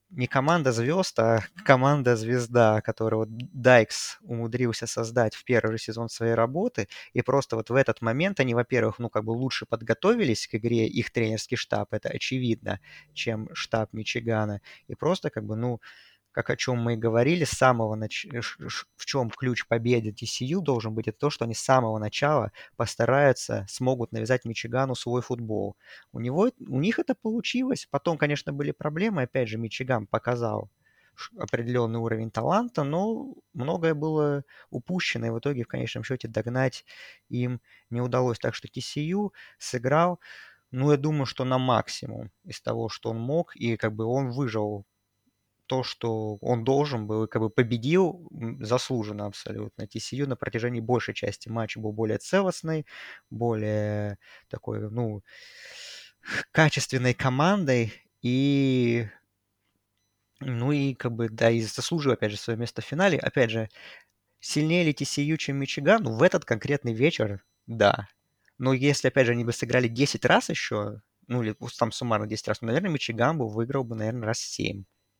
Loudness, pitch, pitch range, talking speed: -27 LUFS, 120 Hz, 110-140 Hz, 160 wpm